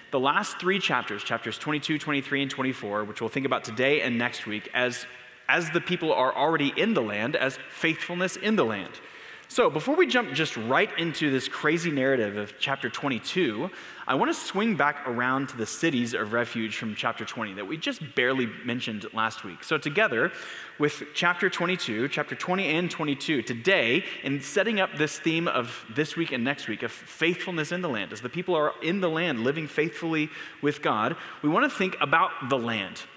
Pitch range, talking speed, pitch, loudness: 120-175 Hz, 195 wpm, 145 Hz, -27 LUFS